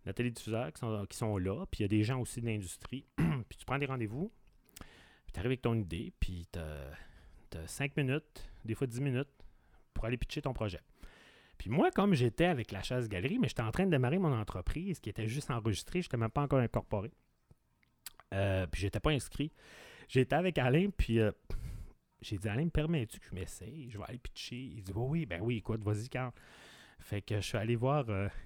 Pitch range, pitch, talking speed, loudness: 100-135 Hz, 115 Hz, 215 wpm, -36 LUFS